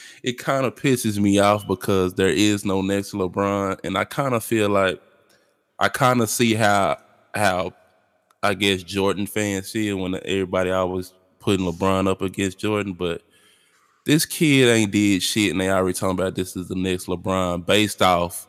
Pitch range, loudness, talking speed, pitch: 95-105 Hz, -21 LUFS, 185 wpm, 100 Hz